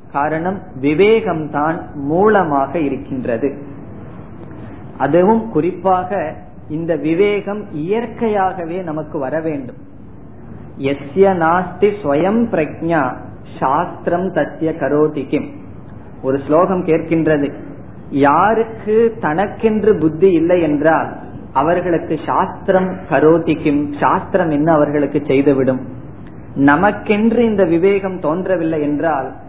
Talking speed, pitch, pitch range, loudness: 65 wpm, 160 Hz, 145-185 Hz, -16 LUFS